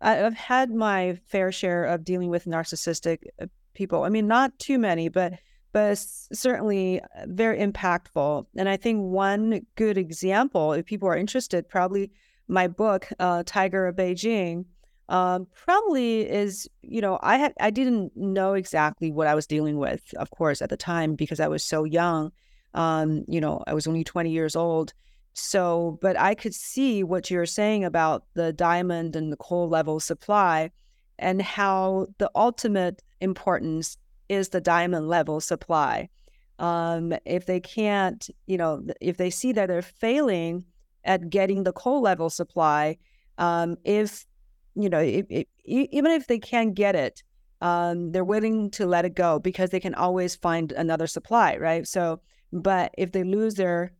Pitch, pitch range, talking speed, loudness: 185 Hz, 170-205 Hz, 165 wpm, -25 LUFS